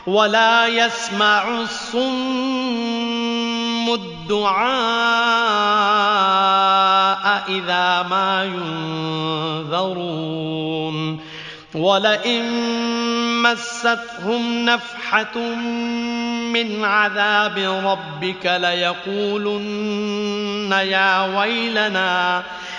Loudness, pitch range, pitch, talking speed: -19 LUFS, 190-235 Hz, 210 Hz, 45 wpm